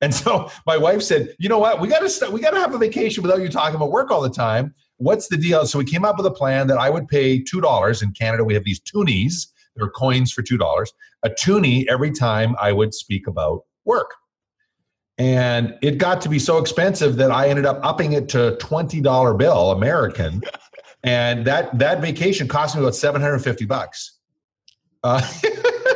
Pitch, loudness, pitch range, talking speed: 145 Hz, -19 LUFS, 125-185 Hz, 210 wpm